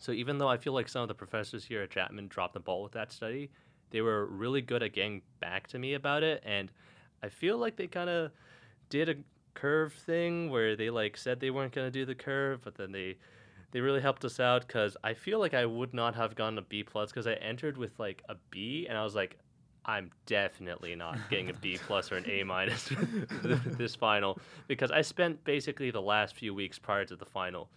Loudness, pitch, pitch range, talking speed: -34 LUFS, 125 Hz, 110-145 Hz, 235 wpm